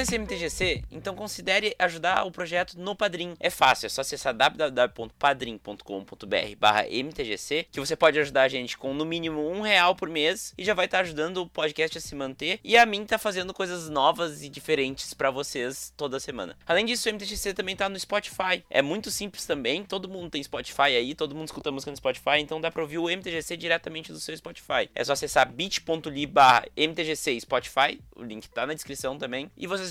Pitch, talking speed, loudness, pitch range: 160 Hz, 200 wpm, -26 LUFS, 140-185 Hz